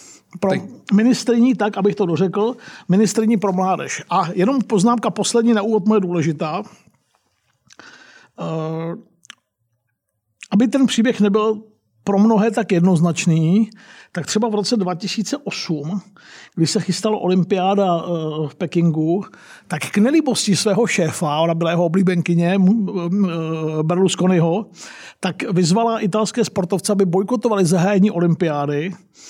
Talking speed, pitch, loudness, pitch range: 110 wpm, 195 Hz, -18 LUFS, 170-215 Hz